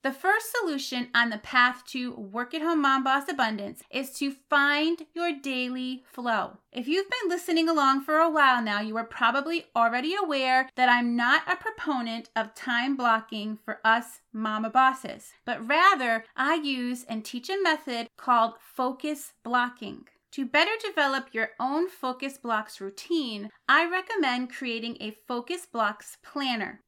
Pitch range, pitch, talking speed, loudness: 230-300 Hz, 255 Hz, 160 wpm, -26 LUFS